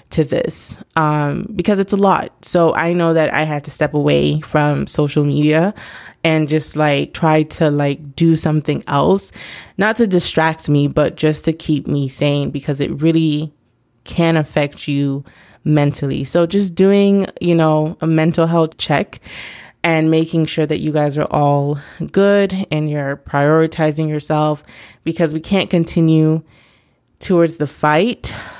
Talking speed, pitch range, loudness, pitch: 155 wpm, 150-165 Hz, -16 LUFS, 155 Hz